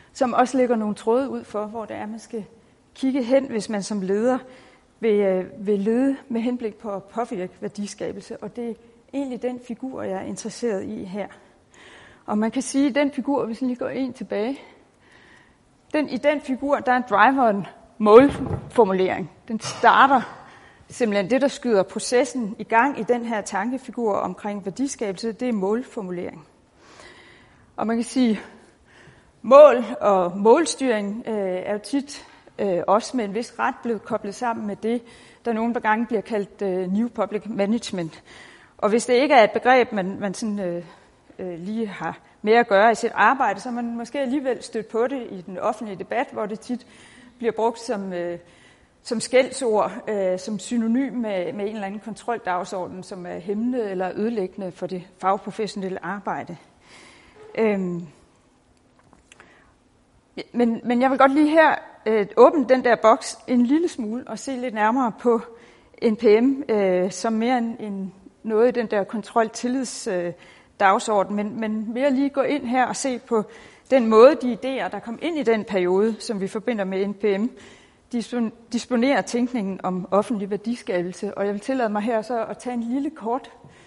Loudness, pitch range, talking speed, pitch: -22 LUFS, 205-245 Hz, 175 wpm, 225 Hz